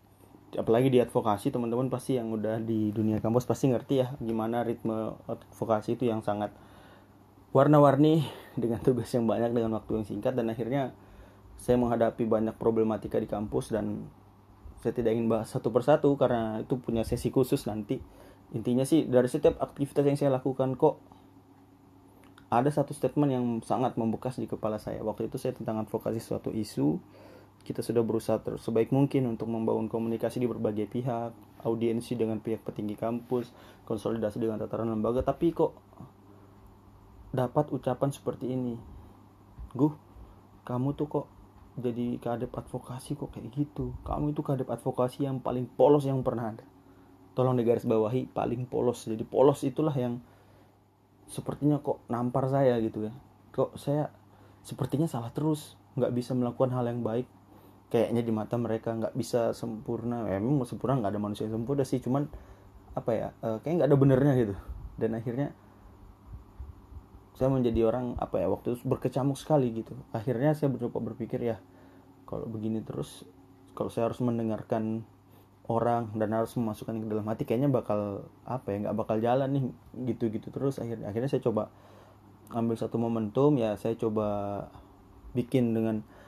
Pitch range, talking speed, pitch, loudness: 105-130 Hz, 155 wpm, 115 Hz, -30 LUFS